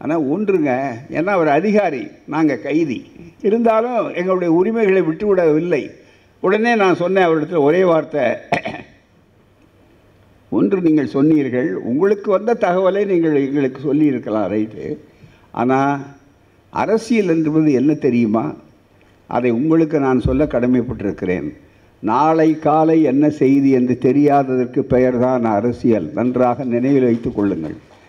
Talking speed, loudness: 105 wpm, -16 LUFS